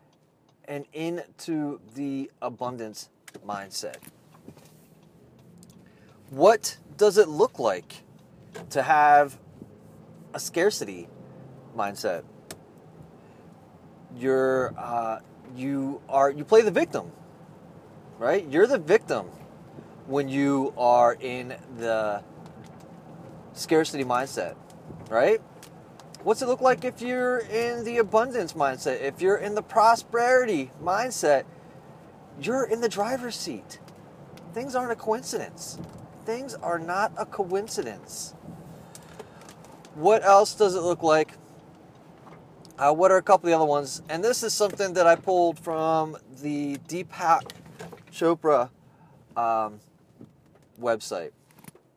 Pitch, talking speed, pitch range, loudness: 165 Hz, 105 wpm, 140-215 Hz, -25 LUFS